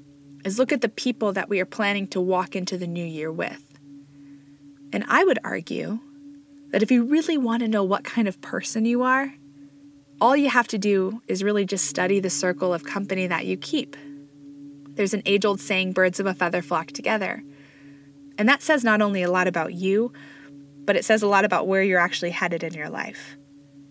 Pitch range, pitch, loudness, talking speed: 145-215 Hz, 185 Hz, -23 LUFS, 205 wpm